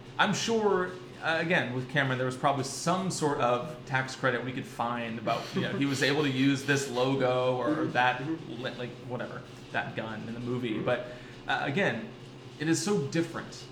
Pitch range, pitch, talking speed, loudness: 125-145 Hz, 130 Hz, 190 wpm, -30 LUFS